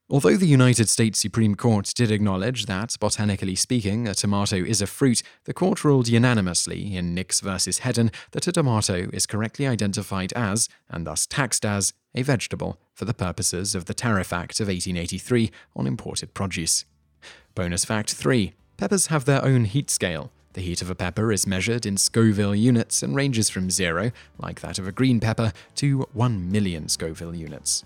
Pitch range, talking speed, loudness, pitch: 95-120 Hz, 180 wpm, -23 LUFS, 105 Hz